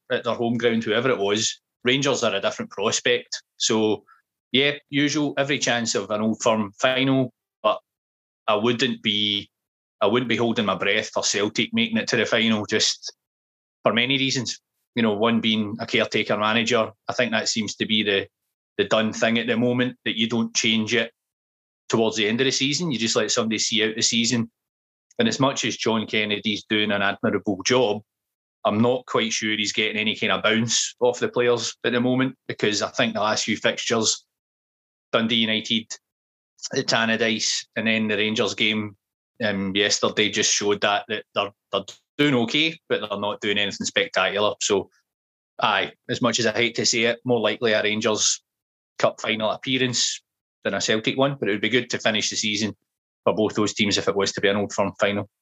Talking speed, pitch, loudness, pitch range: 200 wpm, 115 Hz, -22 LUFS, 105-125 Hz